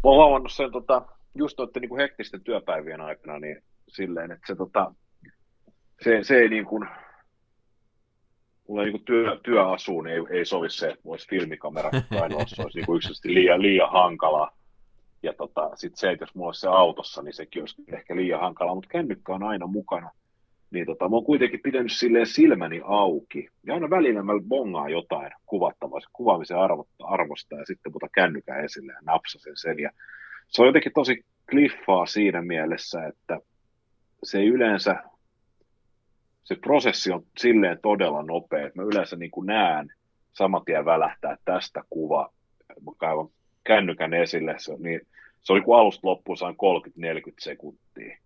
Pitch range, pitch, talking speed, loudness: 95-130 Hz, 115 Hz, 170 wpm, -24 LUFS